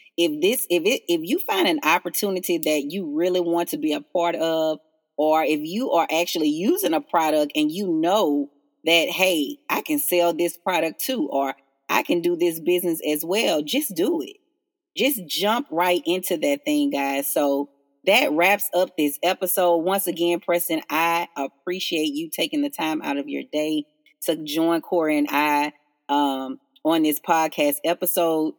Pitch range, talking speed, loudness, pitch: 155-205 Hz, 175 wpm, -22 LUFS, 170 Hz